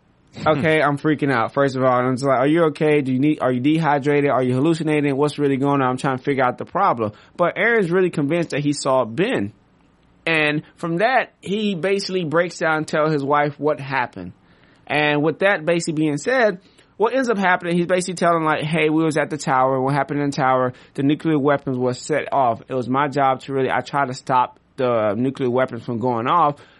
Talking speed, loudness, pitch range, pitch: 225 wpm, -20 LUFS, 130-160 Hz, 145 Hz